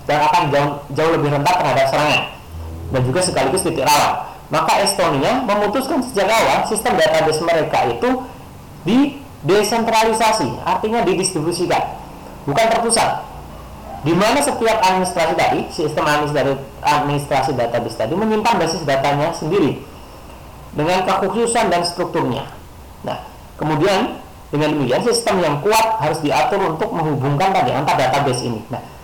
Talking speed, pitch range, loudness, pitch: 130 wpm, 145-220 Hz, -17 LUFS, 170 Hz